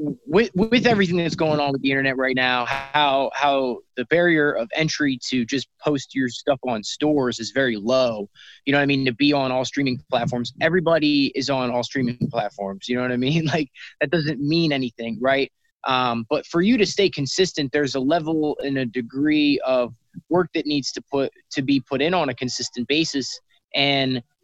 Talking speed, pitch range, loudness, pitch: 205 wpm, 130-155 Hz, -22 LUFS, 140 Hz